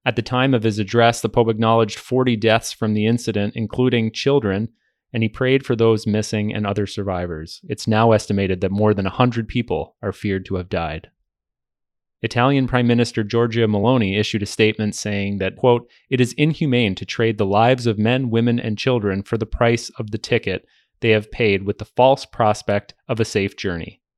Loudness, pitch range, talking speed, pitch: -19 LUFS, 105-120 Hz, 195 wpm, 115 Hz